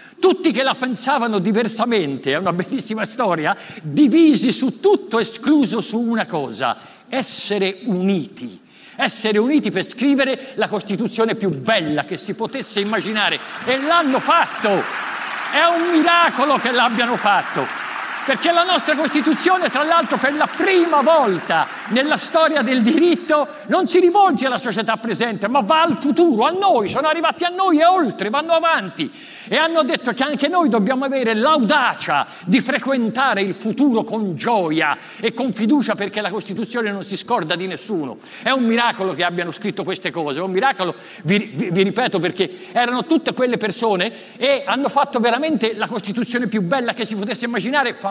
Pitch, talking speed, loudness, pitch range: 245 Hz, 165 wpm, -18 LUFS, 210-295 Hz